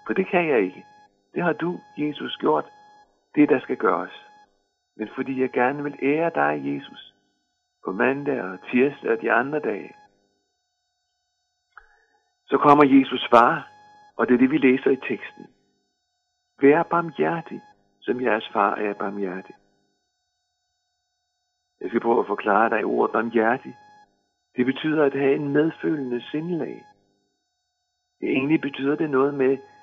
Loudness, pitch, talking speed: -22 LUFS, 195 Hz, 140 wpm